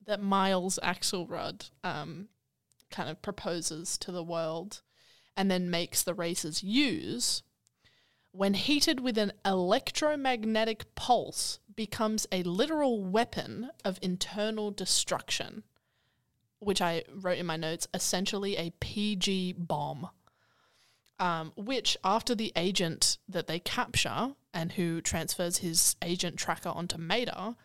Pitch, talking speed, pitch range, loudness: 185 Hz, 120 wpm, 170-215 Hz, -31 LUFS